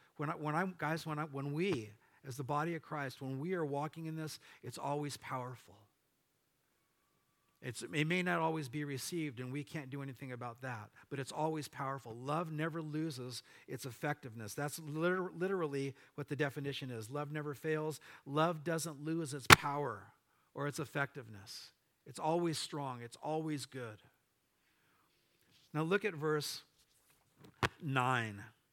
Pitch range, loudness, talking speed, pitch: 135-155 Hz, -38 LUFS, 155 wpm, 145 Hz